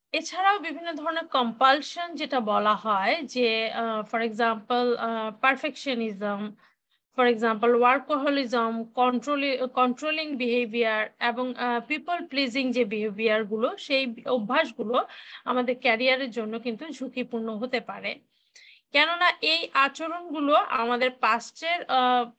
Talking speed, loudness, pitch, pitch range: 90 wpm, -26 LUFS, 250 Hz, 230-290 Hz